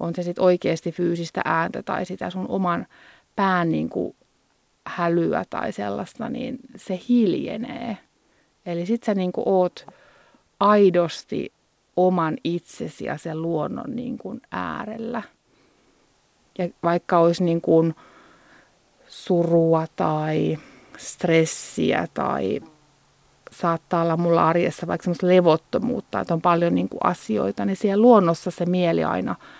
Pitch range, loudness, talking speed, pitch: 165-205 Hz, -23 LUFS, 115 wpm, 175 Hz